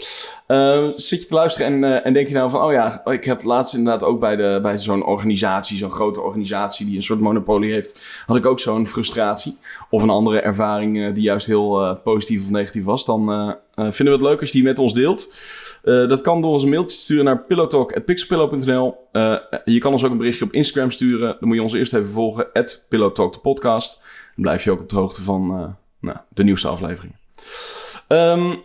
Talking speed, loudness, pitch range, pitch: 230 wpm, -18 LUFS, 105-140 Hz, 120 Hz